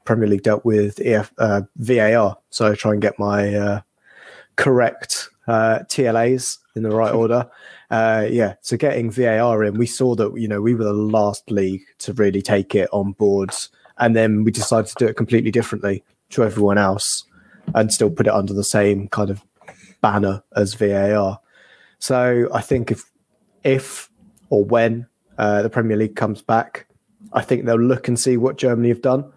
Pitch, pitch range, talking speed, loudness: 110 Hz, 105-120 Hz, 185 wpm, -19 LUFS